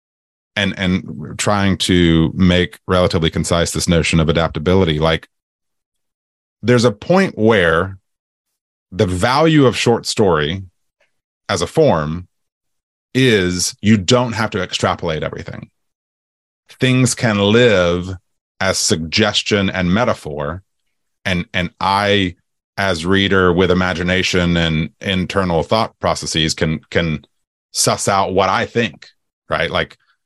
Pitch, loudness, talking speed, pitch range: 90 Hz, -16 LUFS, 115 wpm, 85-105 Hz